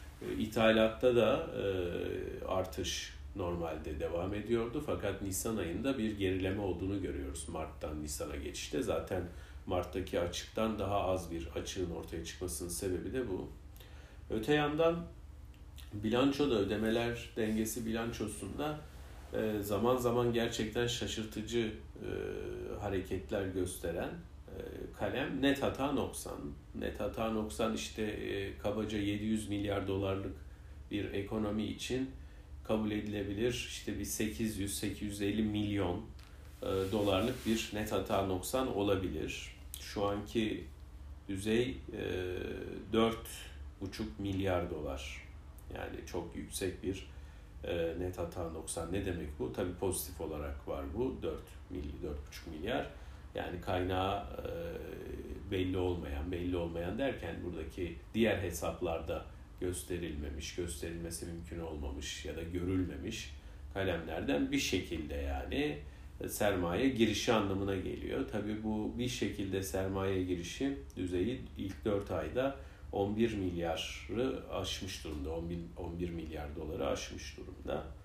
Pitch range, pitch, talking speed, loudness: 80-105 Hz, 95 Hz, 105 wpm, -37 LUFS